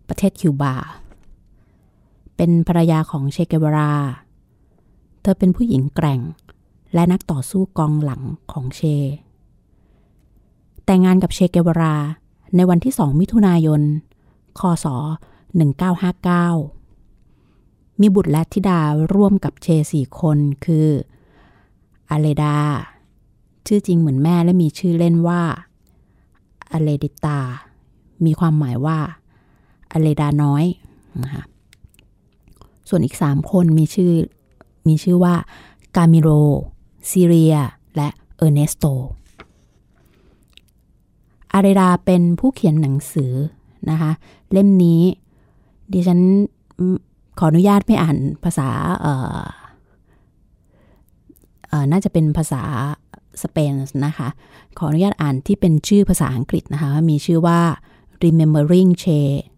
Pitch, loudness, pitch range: 160 Hz, -17 LUFS, 145-175 Hz